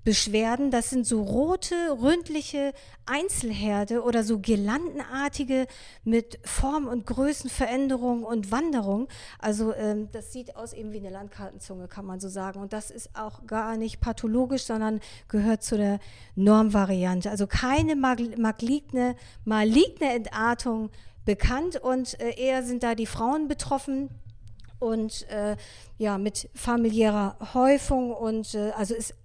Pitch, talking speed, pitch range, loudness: 230 Hz, 135 wpm, 215-260 Hz, -27 LUFS